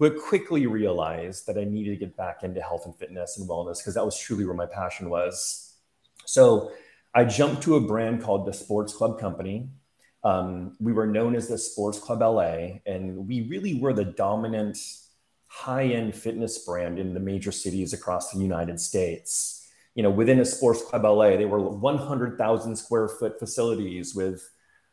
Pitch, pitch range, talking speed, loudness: 105 Hz, 95-115 Hz, 180 wpm, -26 LUFS